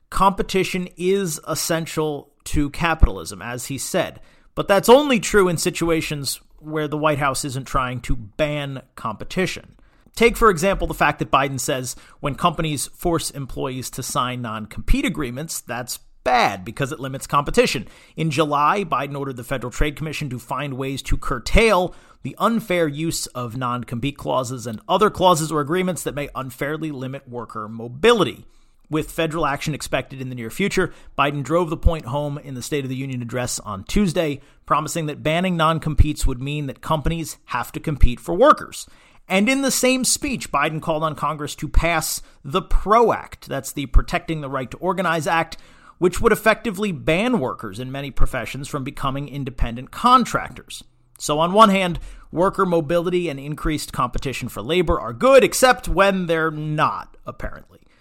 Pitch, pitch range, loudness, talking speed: 150 Hz, 130-175 Hz, -21 LUFS, 170 wpm